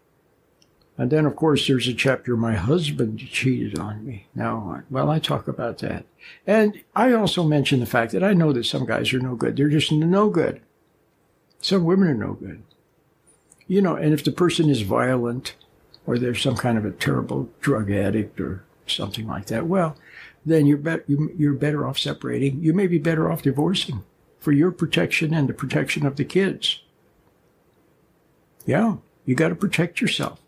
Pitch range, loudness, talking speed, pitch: 125-165 Hz, -22 LUFS, 185 wpm, 145 Hz